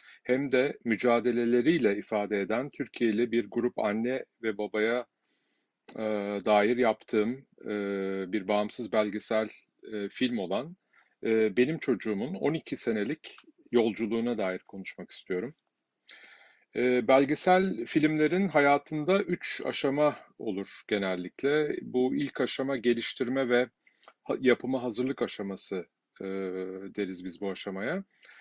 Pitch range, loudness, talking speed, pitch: 105-135 Hz, -29 LUFS, 95 wpm, 120 Hz